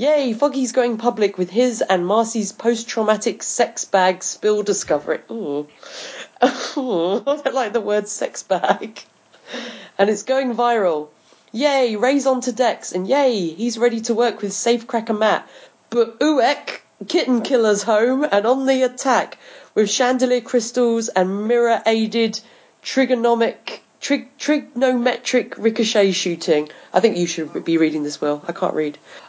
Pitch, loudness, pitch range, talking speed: 230 Hz, -19 LUFS, 205-250 Hz, 140 wpm